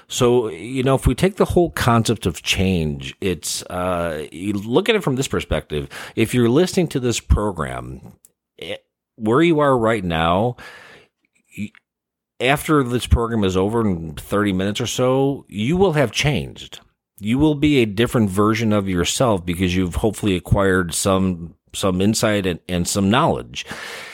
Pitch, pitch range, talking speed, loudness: 110 Hz, 95-135 Hz, 160 wpm, -19 LUFS